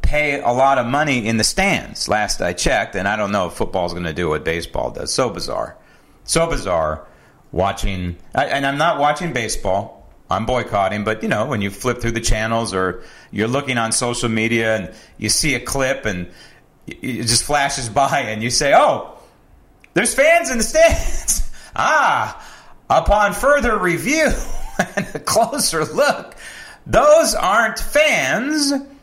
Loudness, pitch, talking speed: -18 LUFS, 125 Hz, 165 wpm